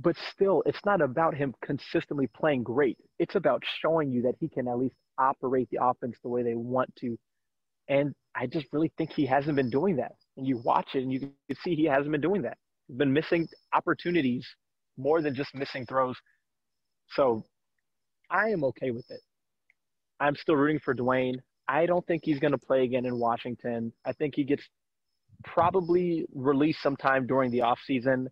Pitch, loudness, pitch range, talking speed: 135 Hz, -29 LUFS, 125-155 Hz, 190 wpm